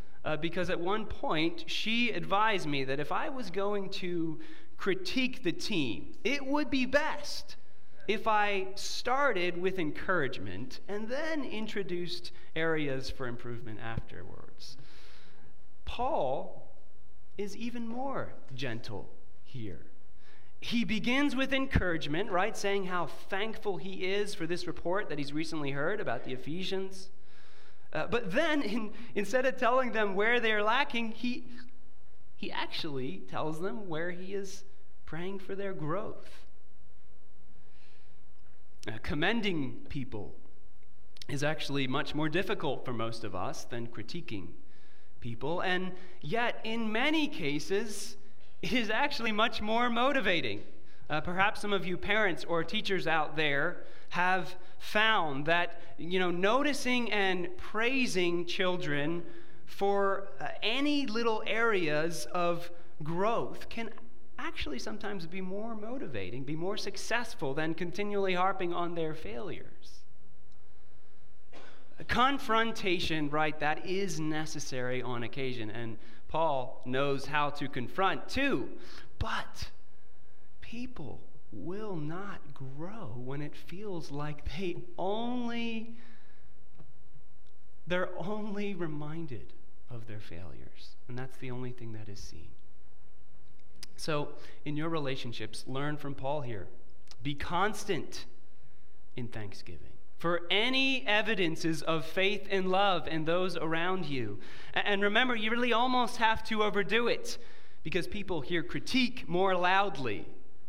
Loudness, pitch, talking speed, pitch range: -33 LUFS, 180 Hz, 125 wpm, 145-215 Hz